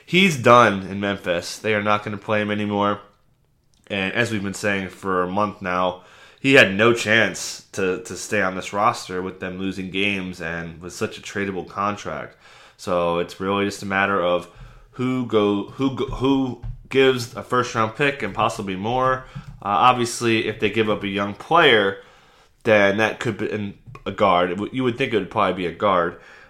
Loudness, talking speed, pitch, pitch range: -21 LUFS, 190 wpm, 105 Hz, 95-120 Hz